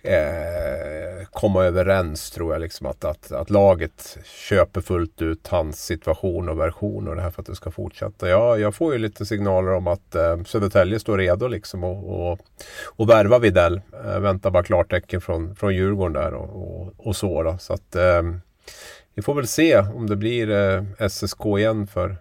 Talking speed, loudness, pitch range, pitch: 185 wpm, -21 LUFS, 90-105 Hz, 95 Hz